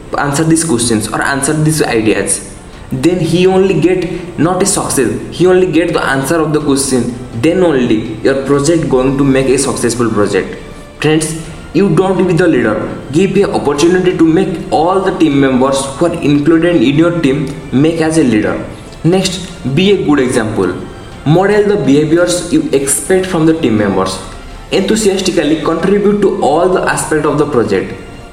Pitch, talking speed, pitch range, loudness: 155 Hz, 170 wpm, 135-175 Hz, -11 LUFS